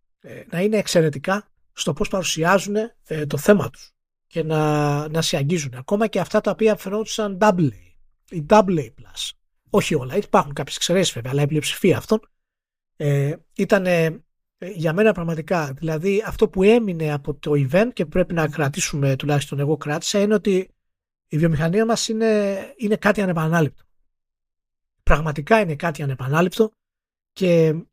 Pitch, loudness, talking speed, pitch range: 170 Hz, -21 LUFS, 145 wpm, 150-205 Hz